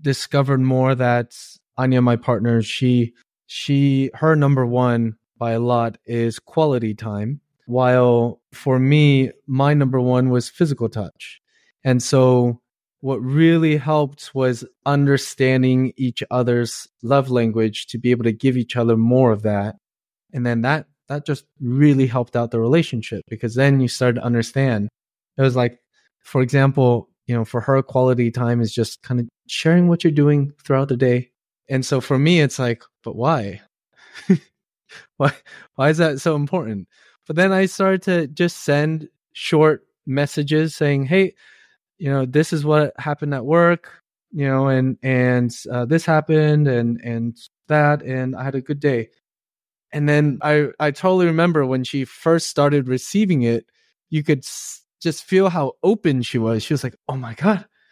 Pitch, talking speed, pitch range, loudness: 135 Hz, 165 wpm, 120-150 Hz, -19 LUFS